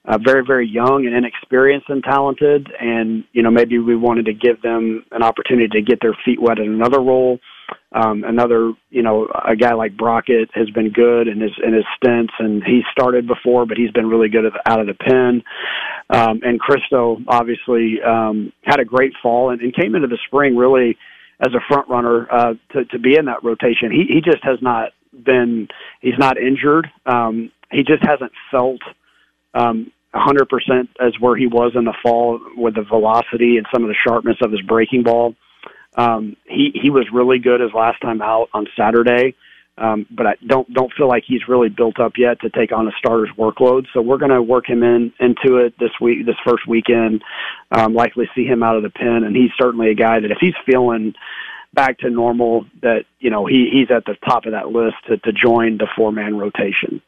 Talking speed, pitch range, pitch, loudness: 215 wpm, 115-125 Hz, 120 Hz, -16 LUFS